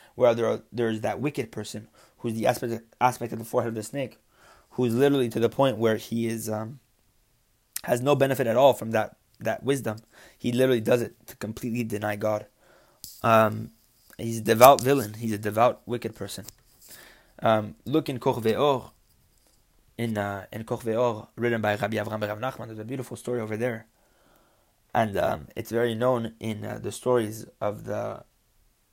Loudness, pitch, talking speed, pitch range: -26 LUFS, 115 Hz, 175 wpm, 110-125 Hz